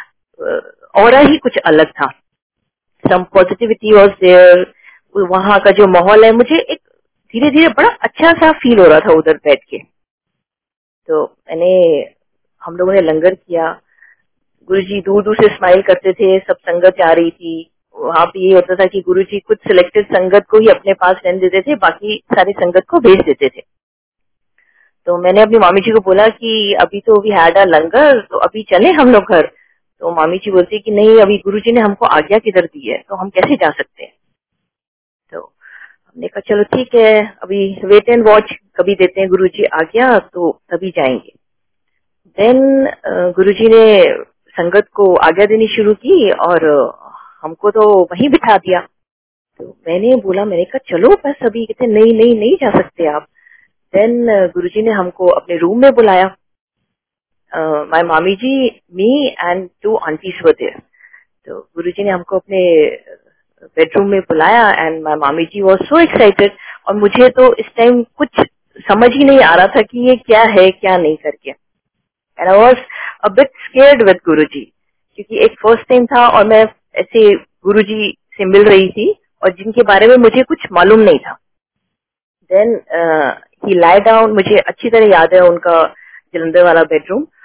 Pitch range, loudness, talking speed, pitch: 185-255 Hz, -10 LUFS, 175 wpm, 205 Hz